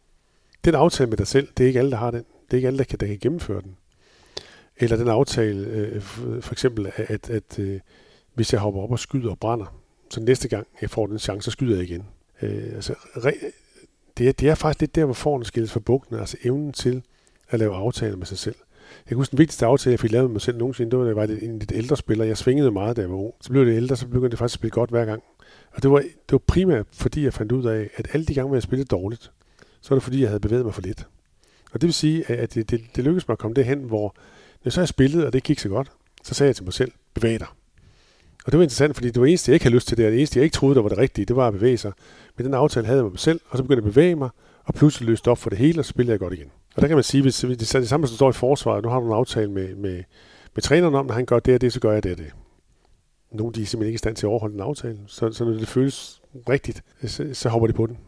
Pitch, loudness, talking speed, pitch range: 120 Hz, -22 LUFS, 305 wpm, 110-135 Hz